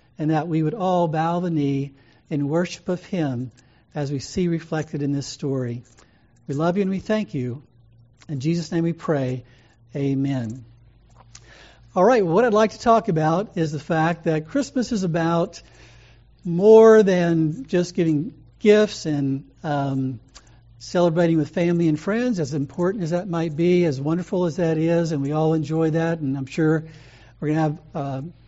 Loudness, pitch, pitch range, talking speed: -22 LUFS, 155 Hz, 135-175 Hz, 175 wpm